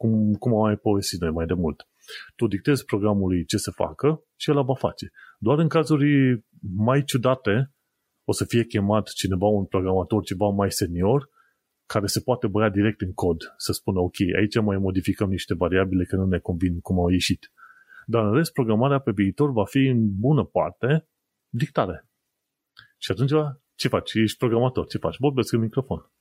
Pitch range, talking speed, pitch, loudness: 95-130 Hz, 180 wpm, 105 Hz, -23 LUFS